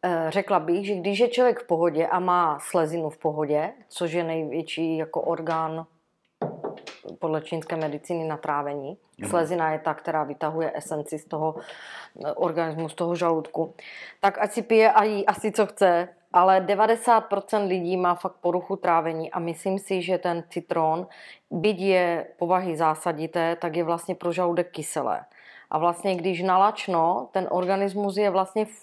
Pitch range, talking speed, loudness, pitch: 160-190 Hz, 155 wpm, -25 LUFS, 175 Hz